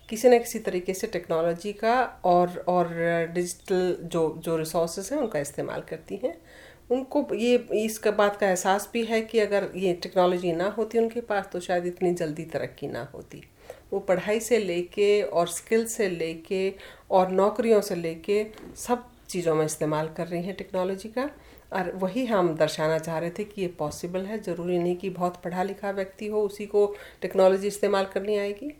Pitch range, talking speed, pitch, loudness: 175-210 Hz, 180 wpm, 190 Hz, -26 LUFS